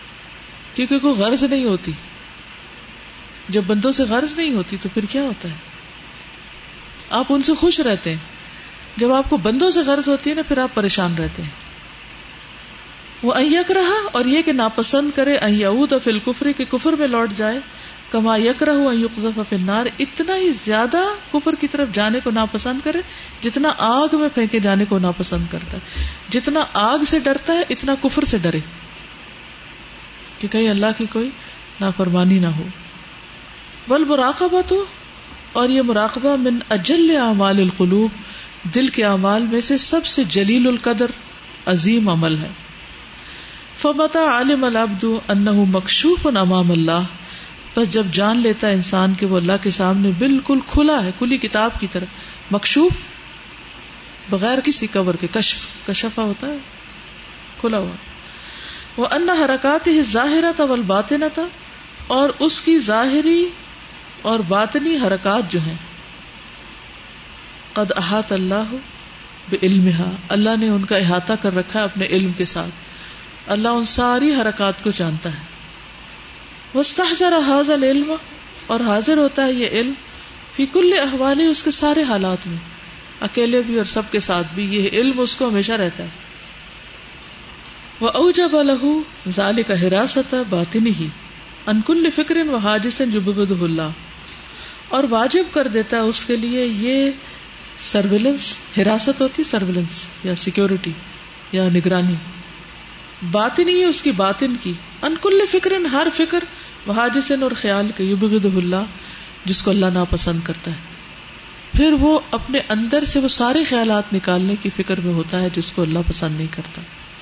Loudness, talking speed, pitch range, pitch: -18 LUFS, 150 wpm, 195-280 Hz, 225 Hz